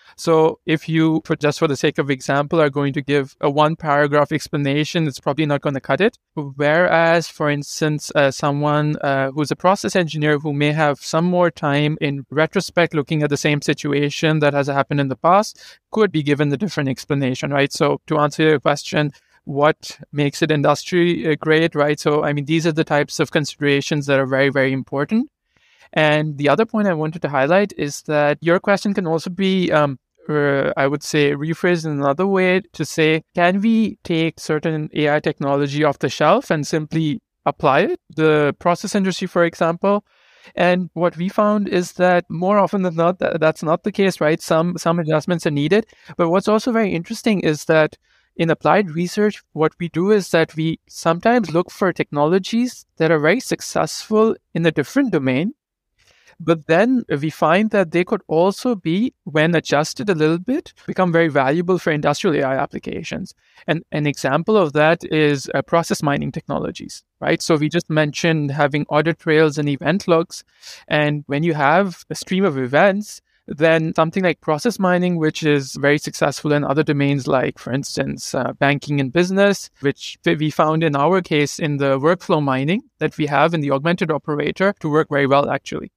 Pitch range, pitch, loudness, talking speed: 145-175 Hz, 160 Hz, -18 LUFS, 190 wpm